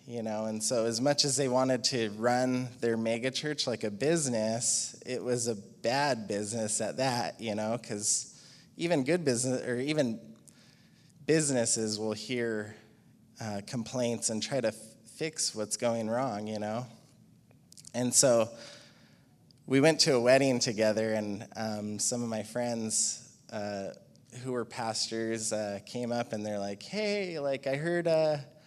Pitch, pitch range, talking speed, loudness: 120 Hz, 110-130 Hz, 160 wpm, -30 LUFS